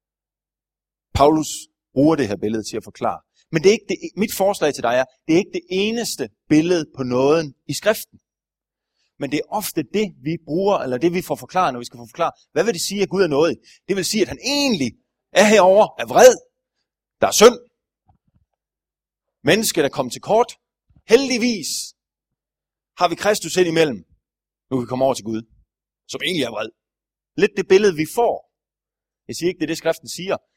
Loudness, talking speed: -19 LUFS, 200 wpm